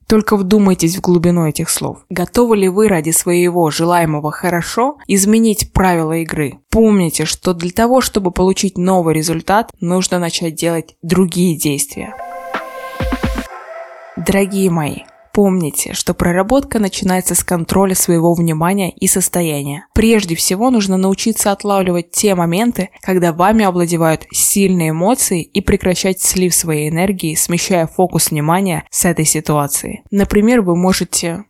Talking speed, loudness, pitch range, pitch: 130 wpm, -14 LUFS, 170-200 Hz, 180 Hz